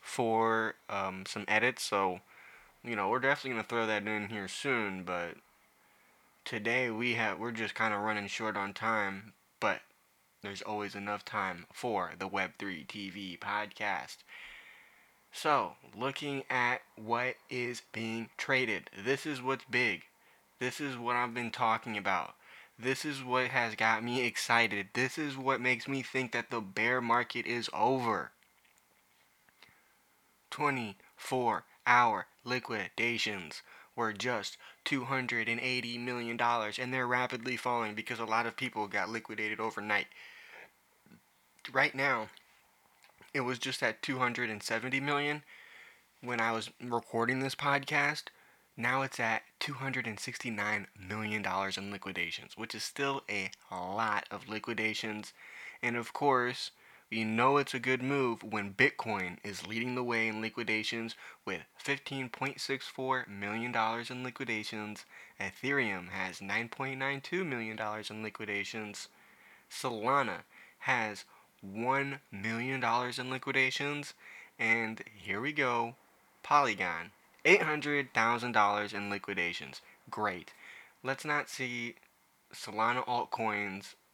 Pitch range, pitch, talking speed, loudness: 110-130 Hz, 115 Hz, 120 wpm, -33 LUFS